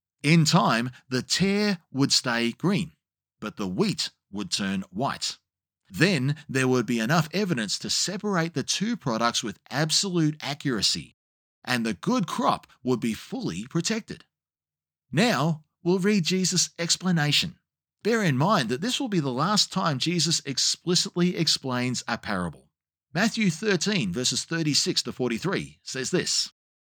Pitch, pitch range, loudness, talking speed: 160 Hz, 125-185 Hz, -25 LUFS, 140 wpm